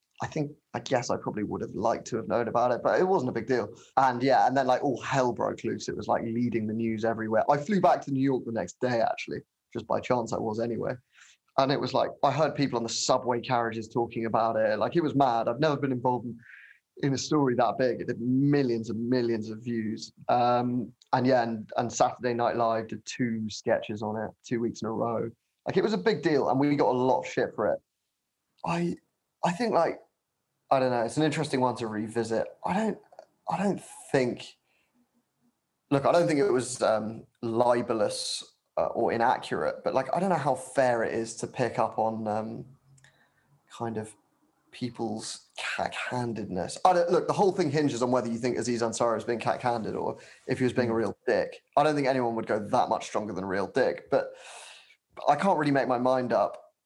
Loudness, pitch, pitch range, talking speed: -28 LUFS, 125 Hz, 115-145 Hz, 225 wpm